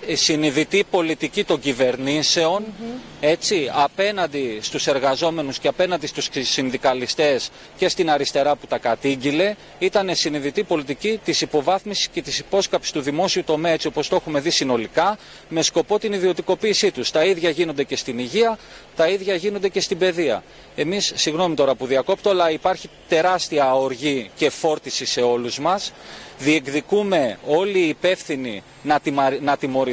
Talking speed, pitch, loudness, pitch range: 150 wpm, 160 Hz, -20 LUFS, 140-185 Hz